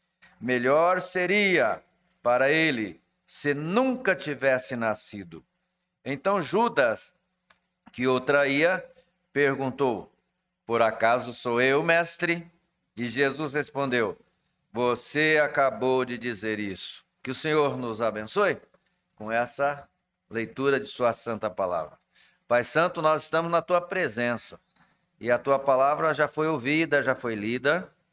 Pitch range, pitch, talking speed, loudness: 120-165 Hz, 140 Hz, 120 wpm, -26 LUFS